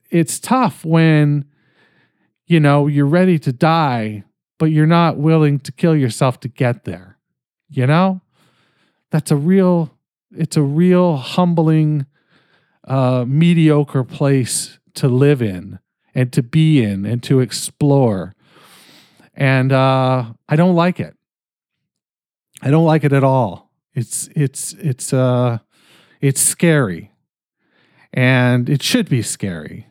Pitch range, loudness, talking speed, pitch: 130-160 Hz, -16 LUFS, 130 wpm, 145 Hz